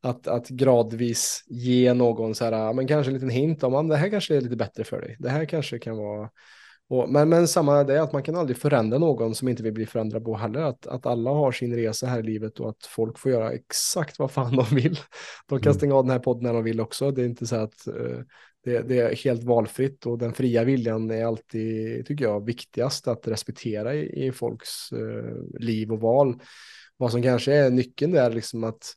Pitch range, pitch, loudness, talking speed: 115-135 Hz, 125 Hz, -25 LUFS, 235 wpm